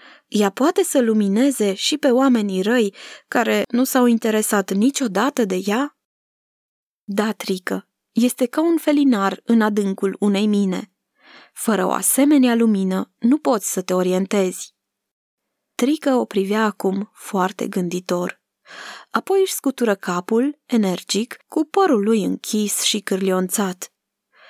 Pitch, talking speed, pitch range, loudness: 220 Hz, 125 wpm, 195-260 Hz, -19 LUFS